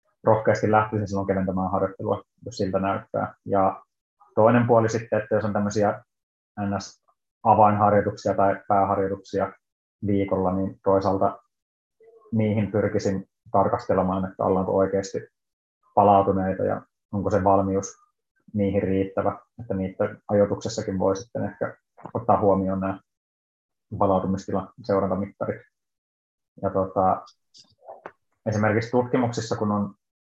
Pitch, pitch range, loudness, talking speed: 100 Hz, 95-105 Hz, -24 LUFS, 105 wpm